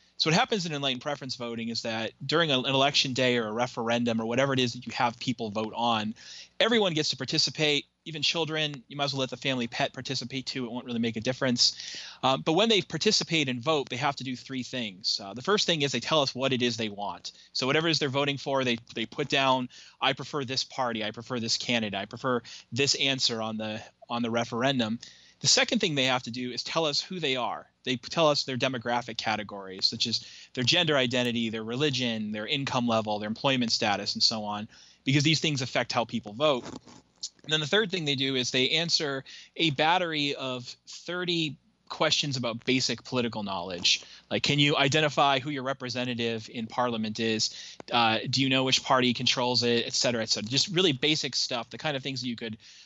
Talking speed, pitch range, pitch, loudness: 220 wpm, 115-145 Hz, 130 Hz, -27 LUFS